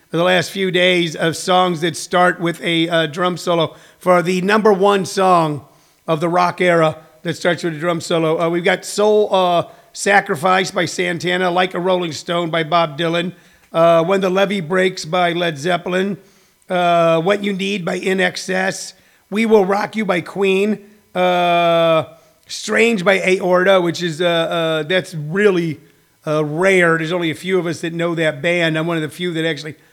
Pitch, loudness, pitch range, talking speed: 175 Hz, -16 LUFS, 165-190 Hz, 185 wpm